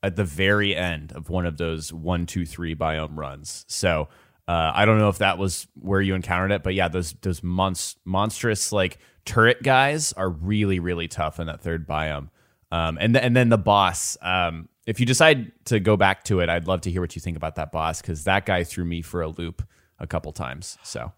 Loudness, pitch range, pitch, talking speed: -23 LUFS, 85-105 Hz, 90 Hz, 225 wpm